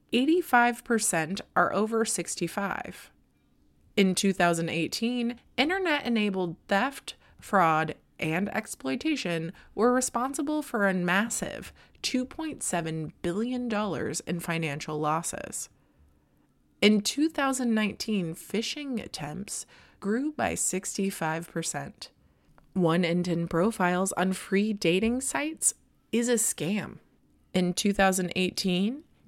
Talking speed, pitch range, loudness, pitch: 85 wpm, 170-235 Hz, -28 LUFS, 200 Hz